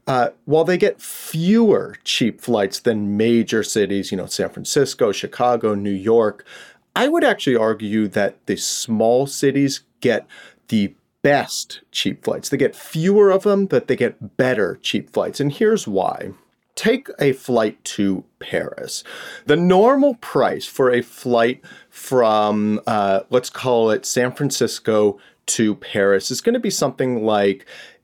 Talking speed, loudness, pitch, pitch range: 150 wpm, -19 LUFS, 125 Hz, 110-180 Hz